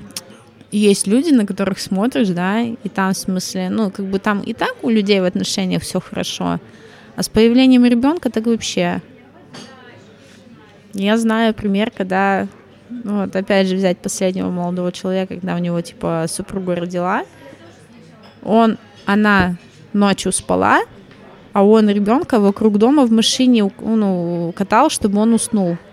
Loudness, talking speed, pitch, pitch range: -17 LUFS, 140 wpm, 200 Hz, 185-225 Hz